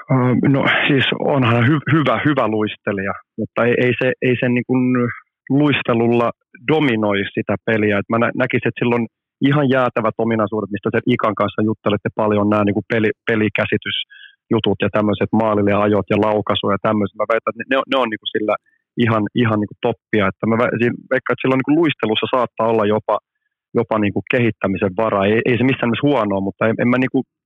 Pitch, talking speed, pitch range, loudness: 115 Hz, 185 wpm, 105-125 Hz, -18 LUFS